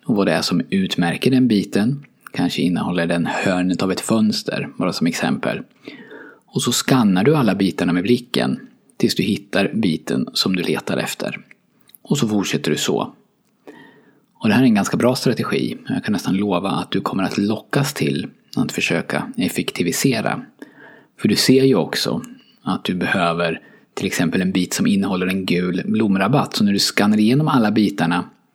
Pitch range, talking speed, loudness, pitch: 90-120 Hz, 175 wpm, -19 LUFS, 100 Hz